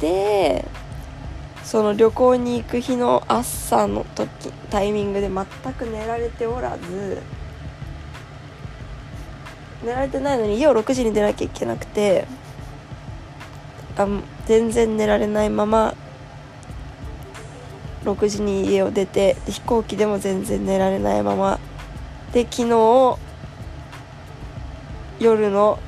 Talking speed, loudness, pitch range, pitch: 195 characters per minute, -20 LUFS, 140-230 Hz, 205 Hz